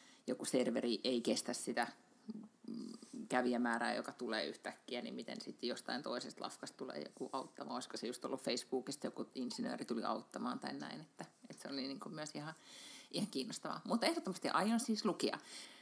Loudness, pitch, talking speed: -41 LUFS, 220 Hz, 165 wpm